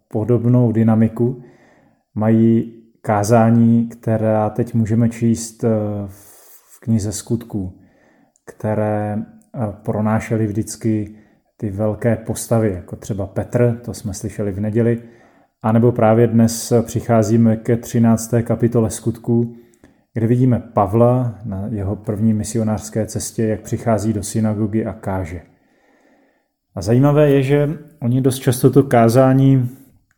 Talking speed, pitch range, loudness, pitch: 115 wpm, 110-120 Hz, -17 LUFS, 115 Hz